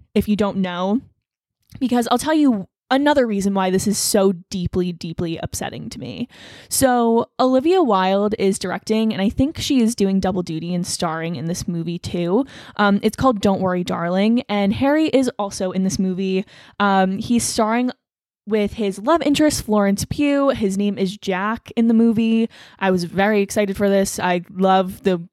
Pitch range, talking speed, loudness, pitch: 190-235 Hz, 180 wpm, -19 LUFS, 200 Hz